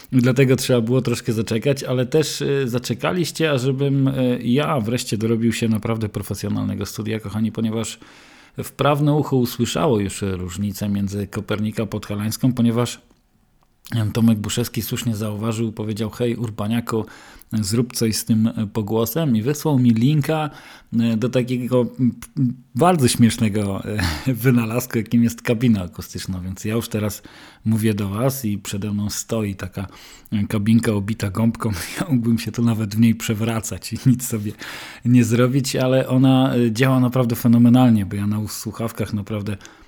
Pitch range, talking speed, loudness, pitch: 110-125 Hz, 140 wpm, -20 LUFS, 115 Hz